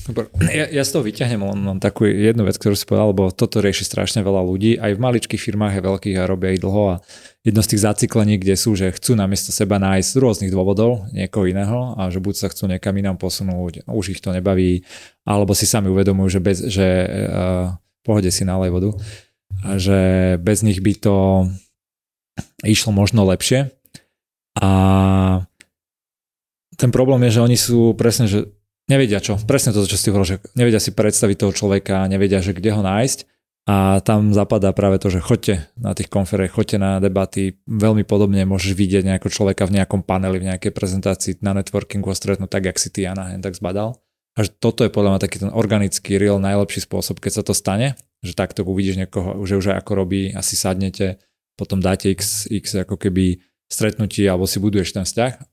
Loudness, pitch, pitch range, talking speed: -18 LUFS, 100 Hz, 95-105 Hz, 200 wpm